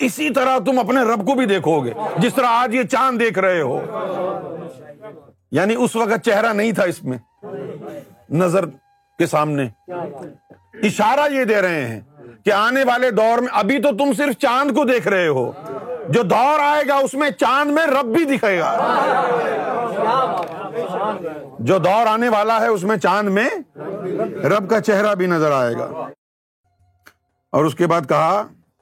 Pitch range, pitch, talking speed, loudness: 175-265 Hz, 220 Hz, 165 wpm, -18 LUFS